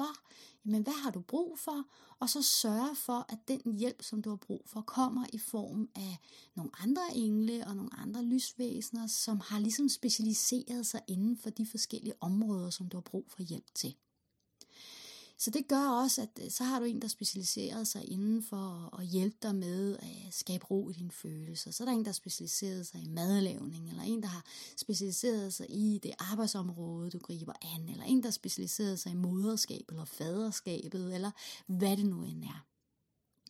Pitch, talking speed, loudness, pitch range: 215 Hz, 190 wpm, -36 LUFS, 185-235 Hz